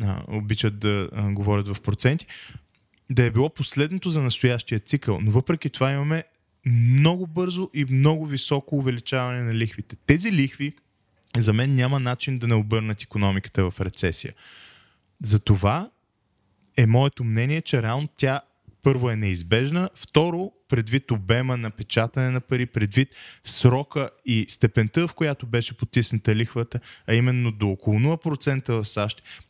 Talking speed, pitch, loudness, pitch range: 140 wpm, 120 Hz, -23 LUFS, 110-140 Hz